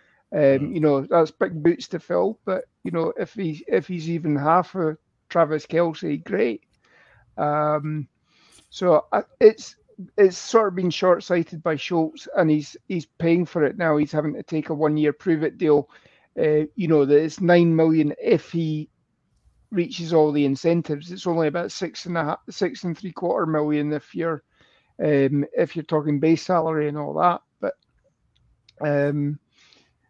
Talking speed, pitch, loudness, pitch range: 175 wpm, 160 Hz, -22 LUFS, 150-170 Hz